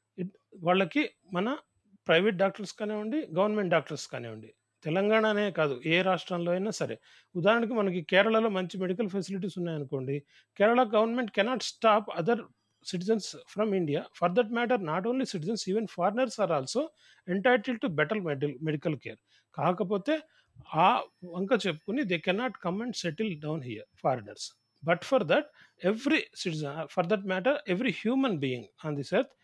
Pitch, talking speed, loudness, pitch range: 195 Hz, 145 wpm, -29 LUFS, 170-225 Hz